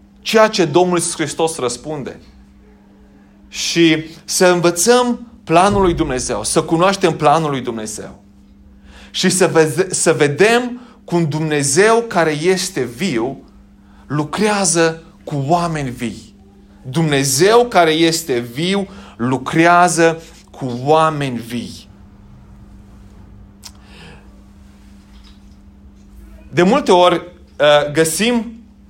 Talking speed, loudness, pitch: 85 wpm, -15 LUFS, 150 Hz